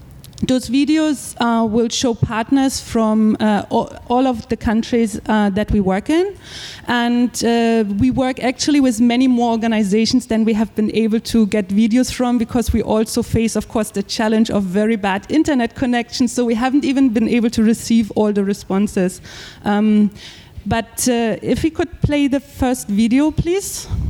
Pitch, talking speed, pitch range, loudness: 230 Hz, 175 wpm, 220-255 Hz, -17 LUFS